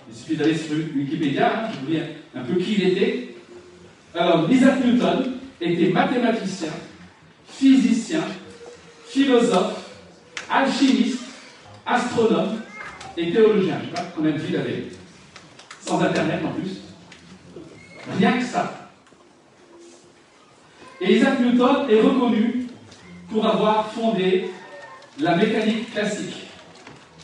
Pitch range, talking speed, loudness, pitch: 170-245 Hz, 115 wpm, -21 LUFS, 220 Hz